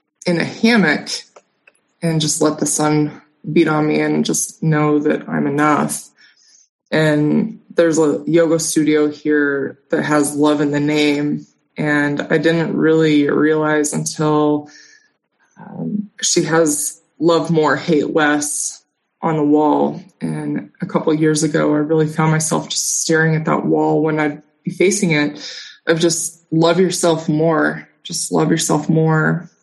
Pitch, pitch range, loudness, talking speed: 155 Hz, 150-165 Hz, -16 LUFS, 150 wpm